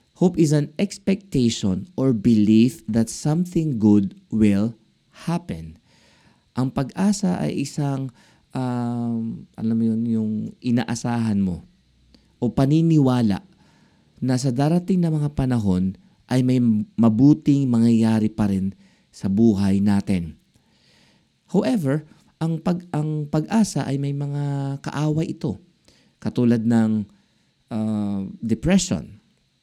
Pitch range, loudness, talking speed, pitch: 110-150 Hz, -21 LUFS, 105 wpm, 125 Hz